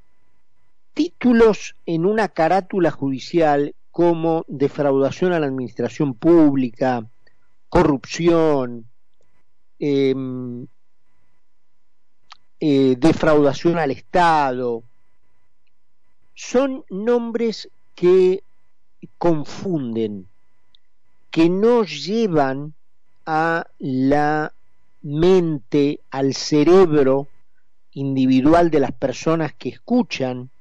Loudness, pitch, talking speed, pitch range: -19 LUFS, 150 Hz, 70 wpm, 130-170 Hz